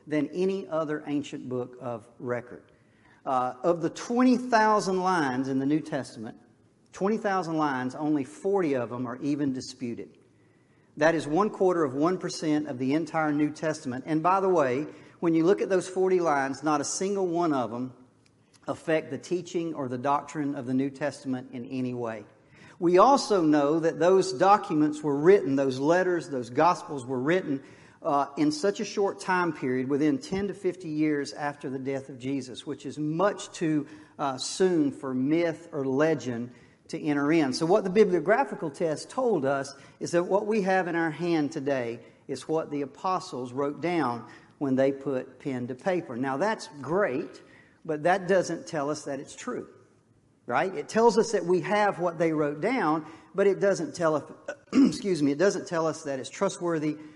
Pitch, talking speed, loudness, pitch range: 155 Hz, 190 wpm, -27 LUFS, 135-180 Hz